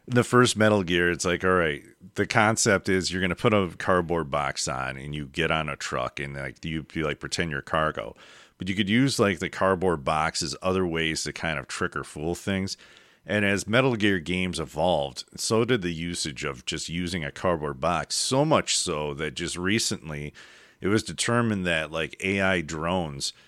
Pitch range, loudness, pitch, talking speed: 80-100 Hz, -26 LUFS, 90 Hz, 205 wpm